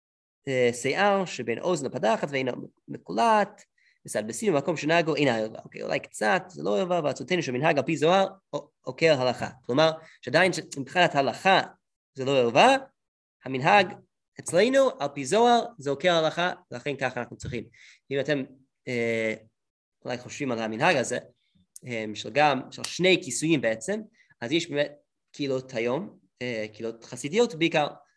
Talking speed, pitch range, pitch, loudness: 135 wpm, 125-180 Hz, 145 Hz, -26 LUFS